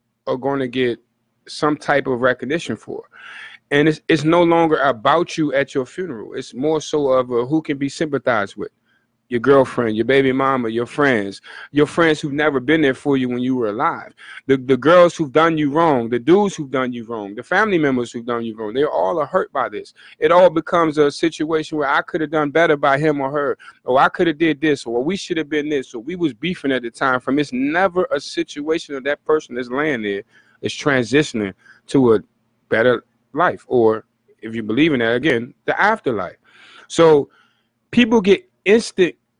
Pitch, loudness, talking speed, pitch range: 145 Hz, -18 LUFS, 215 wpm, 125-165 Hz